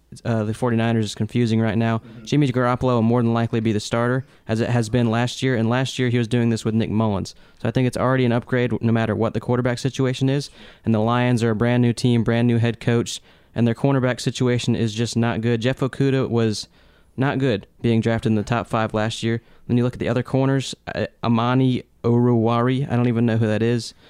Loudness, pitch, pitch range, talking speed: -21 LUFS, 120 Hz, 115-125 Hz, 240 wpm